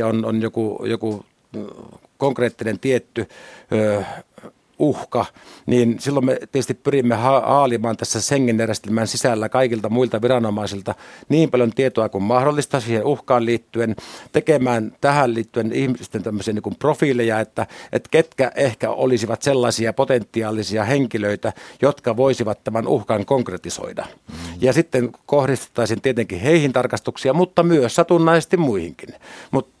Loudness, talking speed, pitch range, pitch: -19 LUFS, 125 wpm, 110-135 Hz, 120 Hz